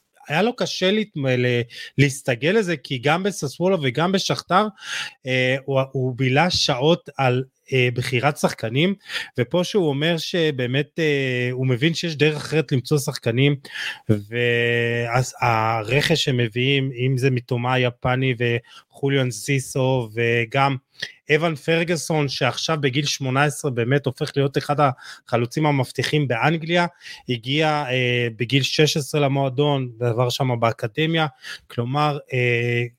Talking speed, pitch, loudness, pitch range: 105 wpm, 140 Hz, -21 LUFS, 125-155 Hz